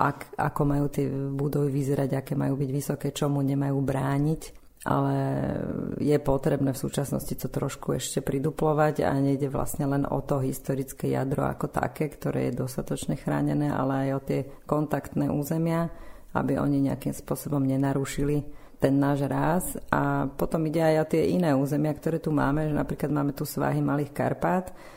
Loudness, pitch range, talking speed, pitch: -27 LUFS, 135-150 Hz, 165 wpm, 140 Hz